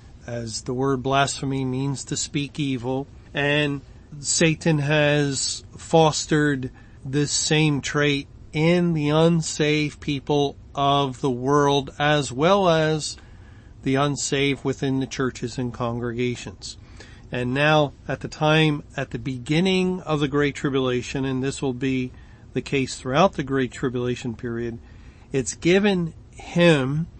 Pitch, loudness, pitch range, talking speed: 135 Hz, -23 LUFS, 125-150 Hz, 130 wpm